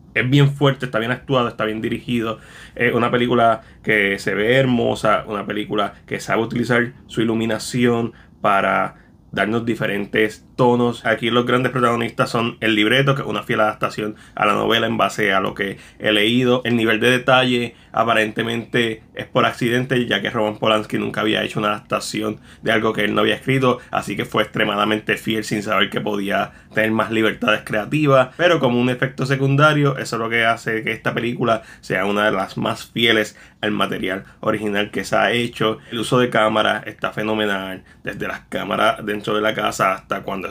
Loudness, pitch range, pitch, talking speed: -19 LUFS, 105-125 Hz, 115 Hz, 190 wpm